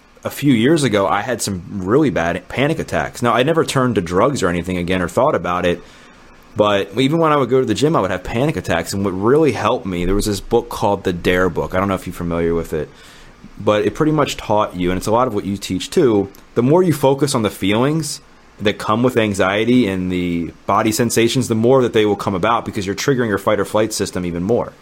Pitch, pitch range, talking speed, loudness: 105 Hz, 95-125 Hz, 255 wpm, -17 LUFS